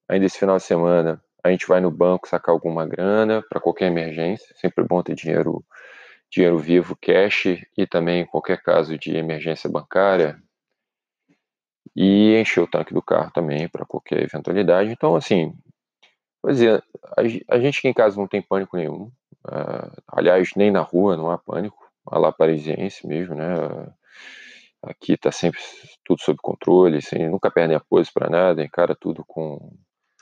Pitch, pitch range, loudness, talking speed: 90 Hz, 85-100 Hz, -20 LUFS, 160 wpm